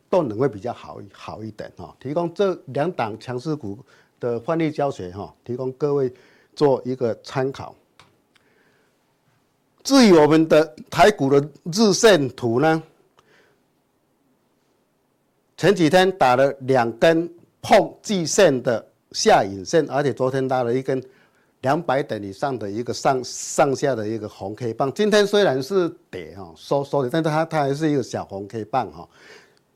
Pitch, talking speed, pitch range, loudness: 140 Hz, 220 characters per minute, 125-165 Hz, -20 LUFS